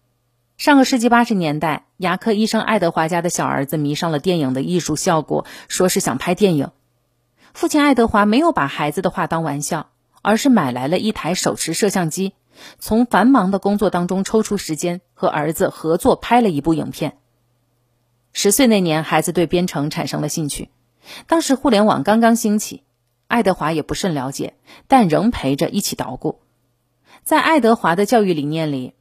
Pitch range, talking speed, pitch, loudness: 150-215 Hz, 280 characters per minute, 175 Hz, -17 LUFS